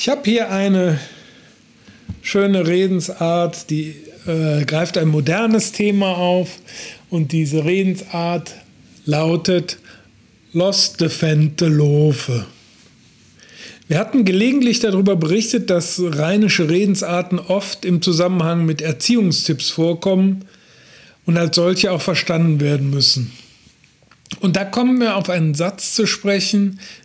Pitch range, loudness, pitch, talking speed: 160-195 Hz, -17 LUFS, 175 Hz, 110 wpm